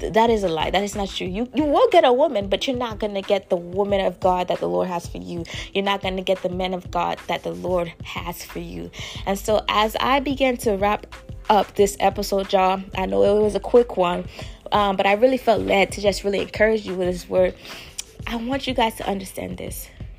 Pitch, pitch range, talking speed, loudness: 195 Hz, 180-215 Hz, 250 wpm, -21 LUFS